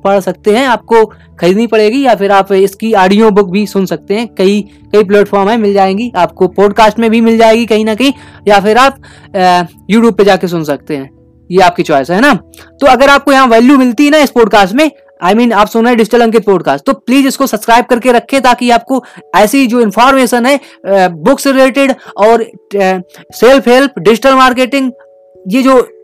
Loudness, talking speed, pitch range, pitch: -8 LUFS, 145 wpm, 195-255 Hz, 225 Hz